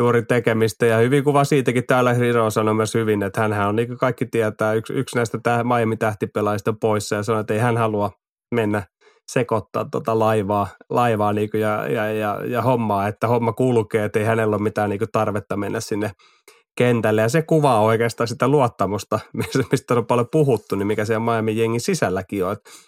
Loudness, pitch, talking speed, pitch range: -20 LUFS, 115 Hz, 185 wpm, 105-120 Hz